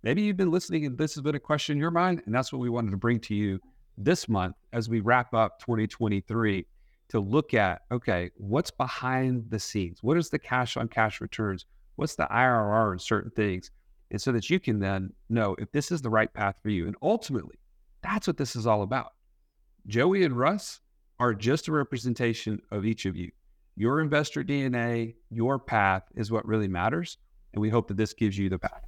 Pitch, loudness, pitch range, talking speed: 115 Hz, -28 LUFS, 105-135 Hz, 210 wpm